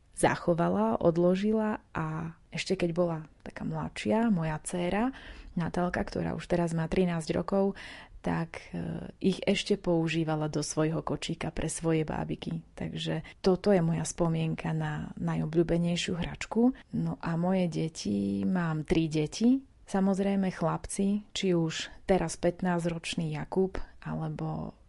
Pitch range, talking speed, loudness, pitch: 155-190 Hz, 120 wpm, -30 LUFS, 170 Hz